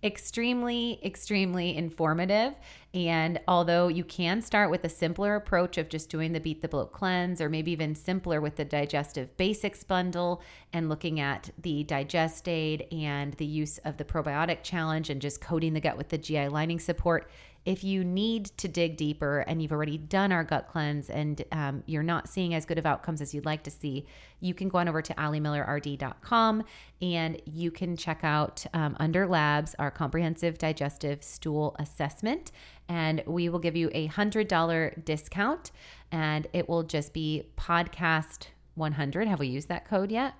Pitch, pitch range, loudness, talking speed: 160 Hz, 150-175 Hz, -30 LUFS, 180 wpm